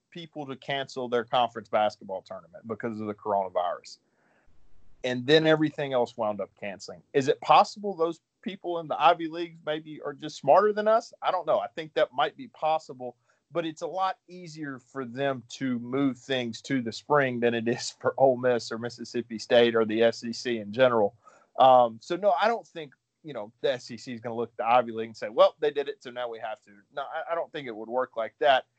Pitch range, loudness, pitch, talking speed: 115-160 Hz, -27 LUFS, 130 Hz, 225 wpm